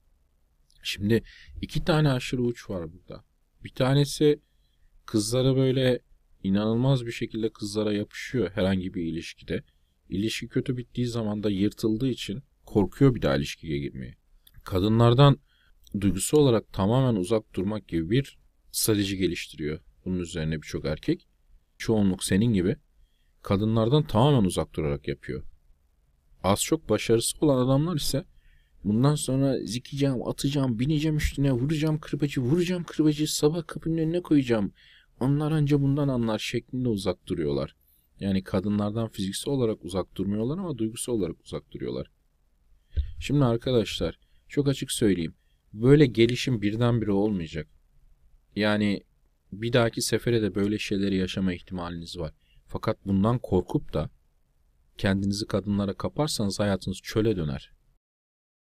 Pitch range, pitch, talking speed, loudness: 80-130 Hz, 105 Hz, 125 wpm, -26 LUFS